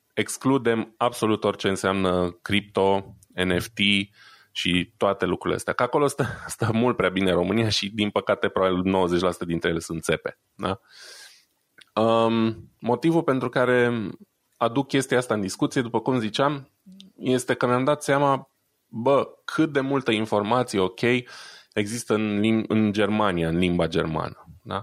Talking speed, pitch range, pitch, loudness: 140 wpm, 95-125 Hz, 110 Hz, -24 LUFS